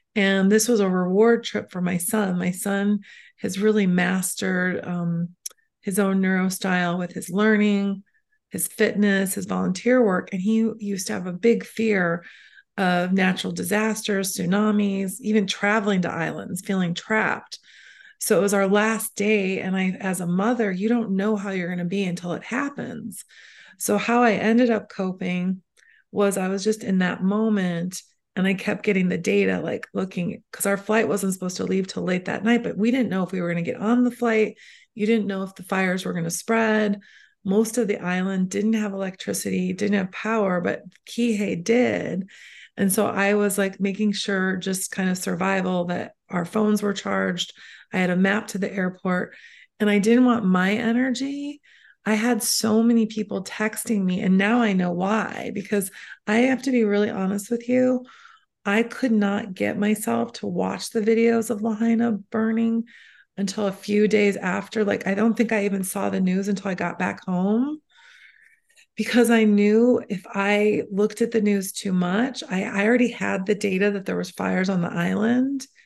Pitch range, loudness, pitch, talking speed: 190-225 Hz, -23 LUFS, 205 Hz, 190 wpm